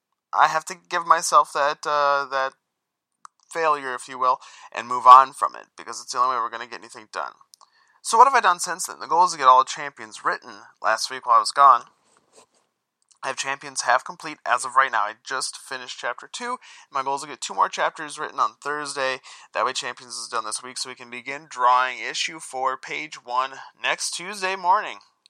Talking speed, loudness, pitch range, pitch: 225 wpm, -22 LUFS, 130-160 Hz, 140 Hz